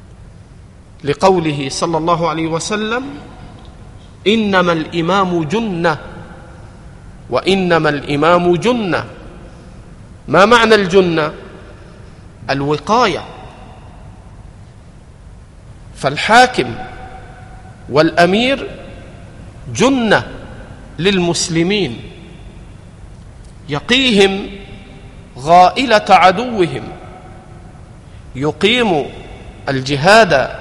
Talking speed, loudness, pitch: 45 wpm, -13 LUFS, 160 Hz